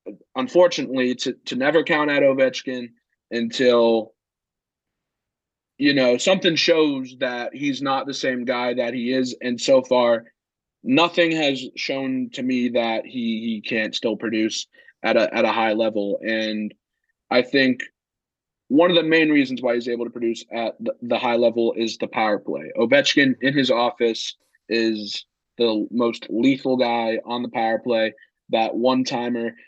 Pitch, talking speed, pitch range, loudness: 125 Hz, 160 wpm, 115-140 Hz, -21 LUFS